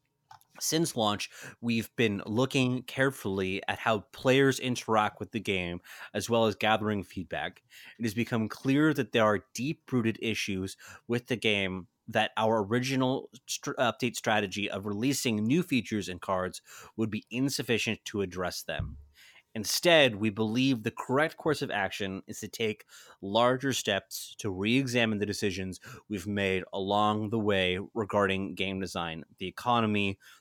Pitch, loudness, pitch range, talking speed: 110 Hz, -30 LUFS, 100-120 Hz, 150 wpm